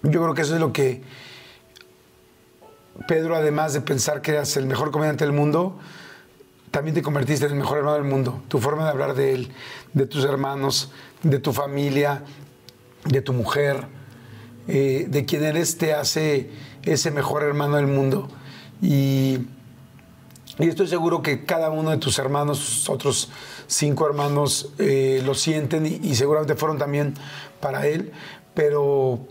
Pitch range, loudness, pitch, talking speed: 135-155 Hz, -22 LUFS, 145 Hz, 160 wpm